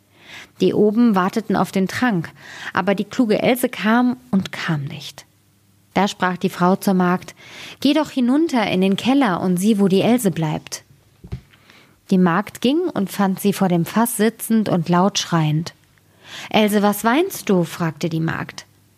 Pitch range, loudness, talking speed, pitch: 165-225 Hz, -19 LUFS, 165 wpm, 190 Hz